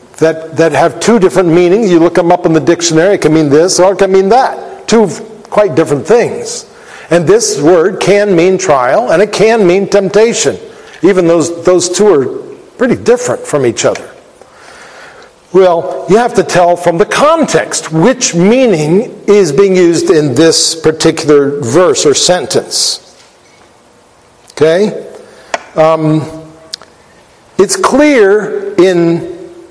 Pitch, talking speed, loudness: 190 Hz, 145 wpm, -8 LUFS